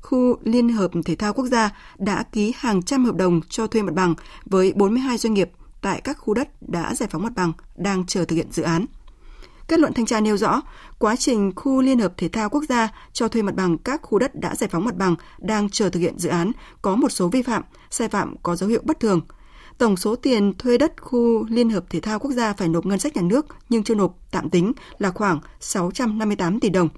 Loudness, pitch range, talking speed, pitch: -22 LUFS, 185-245 Hz, 240 wpm, 215 Hz